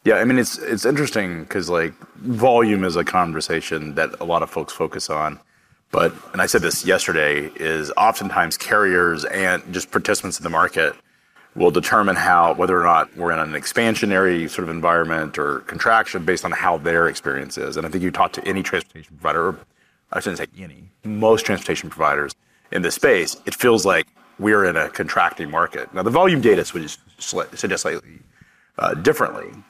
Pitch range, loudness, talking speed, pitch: 80-110 Hz, -19 LUFS, 185 wpm, 85 Hz